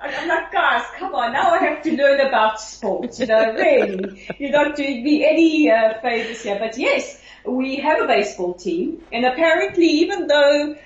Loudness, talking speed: -18 LUFS, 190 wpm